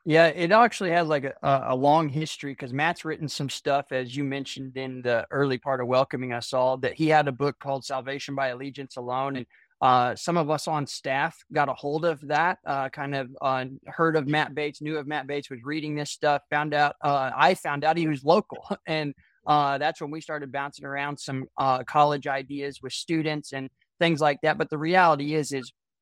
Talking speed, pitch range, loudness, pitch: 220 wpm, 135-155 Hz, -26 LUFS, 145 Hz